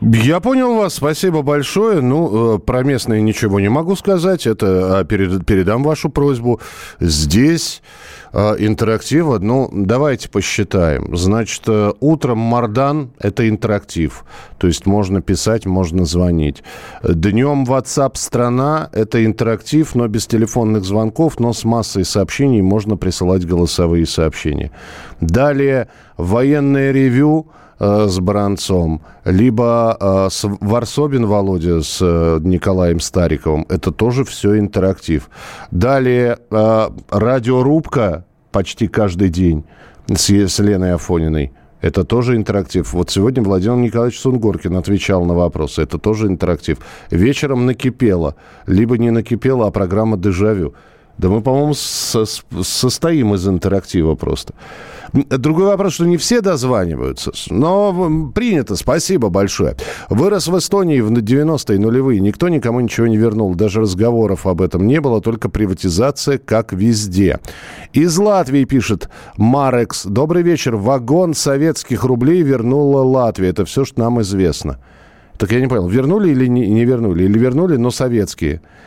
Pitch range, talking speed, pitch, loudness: 95-130 Hz, 125 wpm, 110 Hz, -15 LUFS